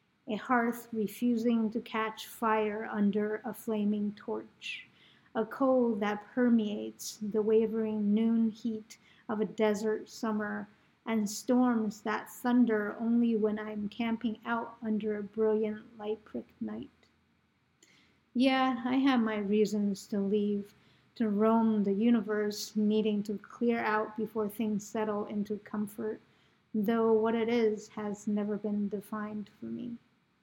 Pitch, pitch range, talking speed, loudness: 215 Hz, 210-230 Hz, 130 wpm, -32 LUFS